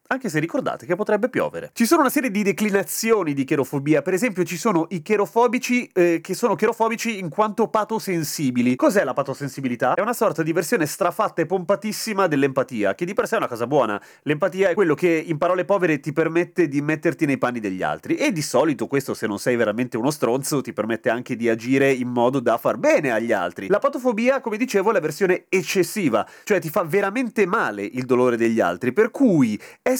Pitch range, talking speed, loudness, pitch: 140-215 Hz, 210 wpm, -21 LUFS, 180 Hz